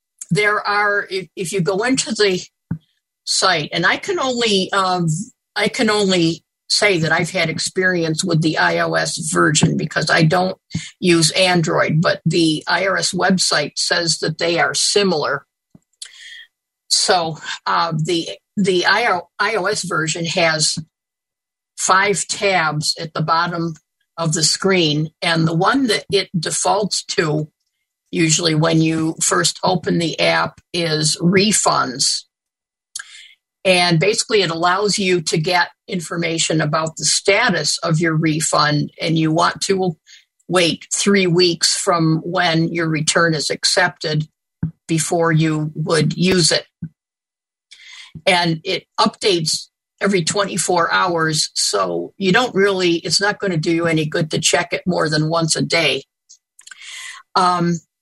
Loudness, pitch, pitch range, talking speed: -17 LUFS, 175 Hz, 160-190 Hz, 135 wpm